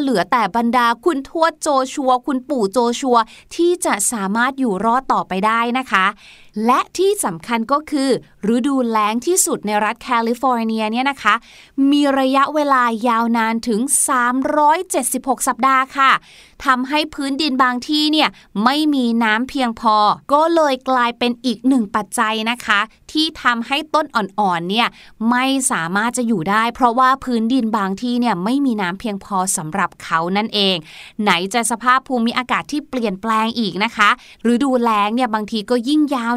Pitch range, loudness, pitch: 220-270 Hz, -17 LUFS, 245 Hz